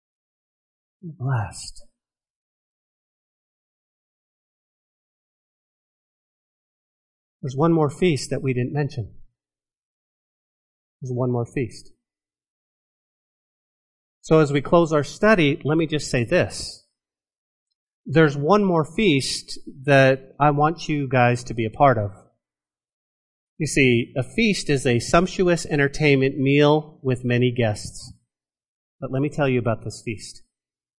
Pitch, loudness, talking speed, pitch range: 135 Hz, -21 LUFS, 110 wpm, 115-150 Hz